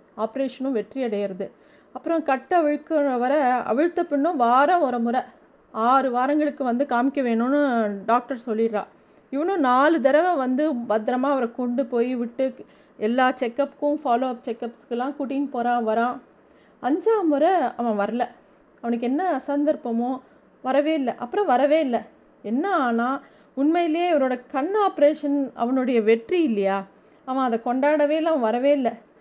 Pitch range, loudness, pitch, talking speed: 240-290 Hz, -23 LUFS, 260 Hz, 130 wpm